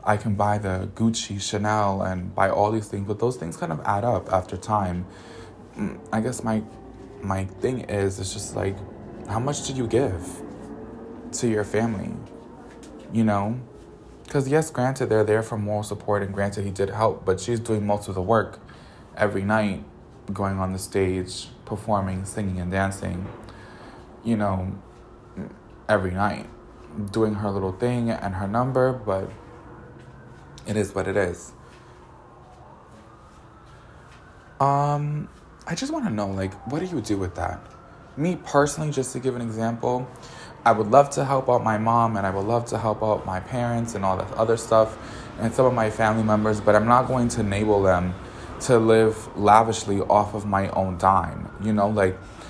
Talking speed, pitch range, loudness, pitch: 175 wpm, 100-115 Hz, -24 LUFS, 105 Hz